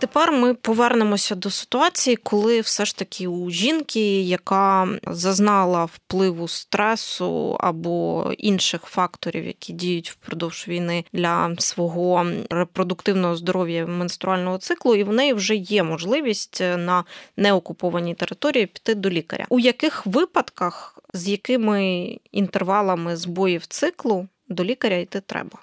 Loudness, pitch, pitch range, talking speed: -22 LUFS, 195 Hz, 175-220 Hz, 120 wpm